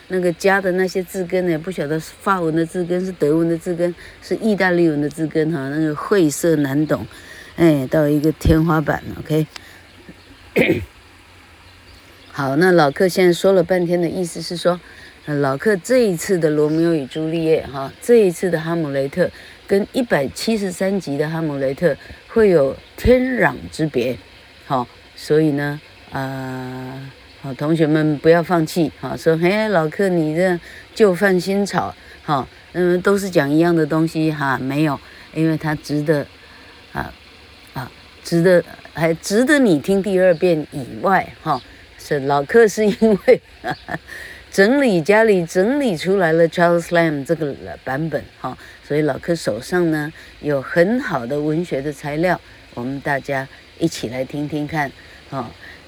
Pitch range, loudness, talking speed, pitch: 145-180 Hz, -18 LUFS, 240 characters per minute, 160 Hz